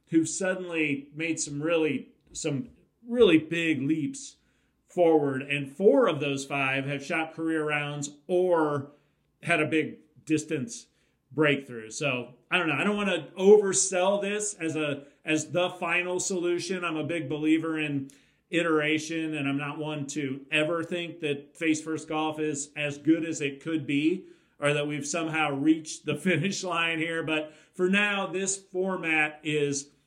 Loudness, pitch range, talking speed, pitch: -27 LUFS, 145-175 Hz, 160 wpm, 160 Hz